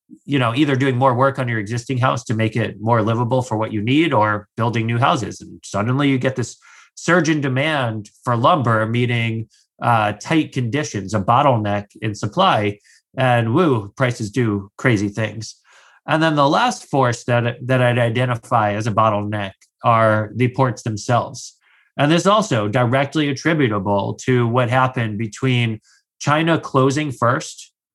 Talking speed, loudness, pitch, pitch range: 165 wpm, -18 LUFS, 120 Hz, 110-135 Hz